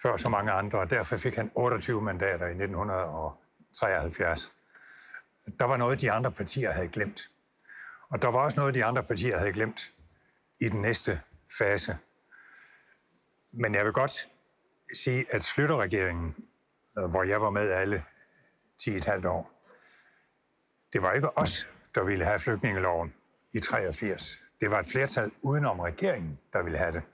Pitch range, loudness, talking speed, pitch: 95-125 Hz, -30 LUFS, 150 wpm, 105 Hz